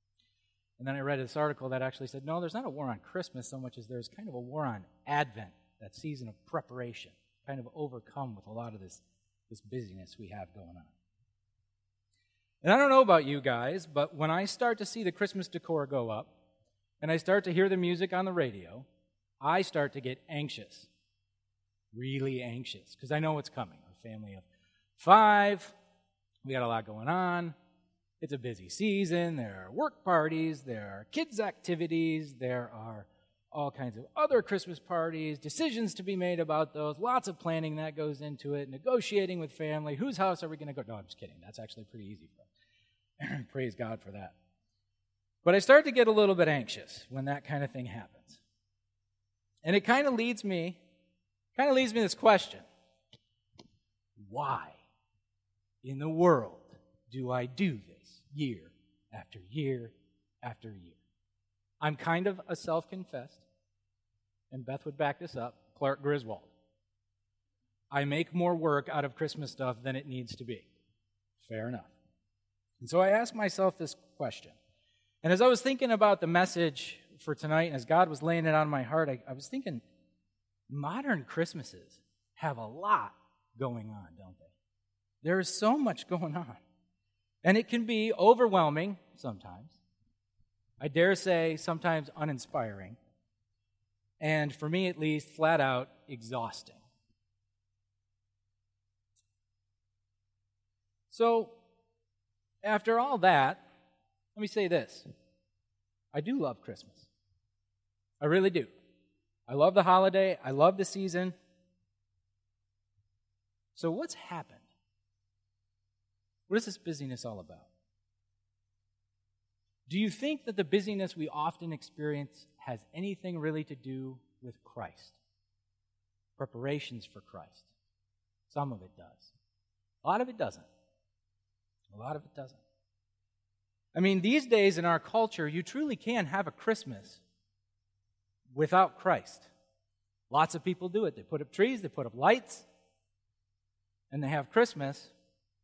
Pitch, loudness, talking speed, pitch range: 125 Hz, -31 LUFS, 155 wpm, 100-165 Hz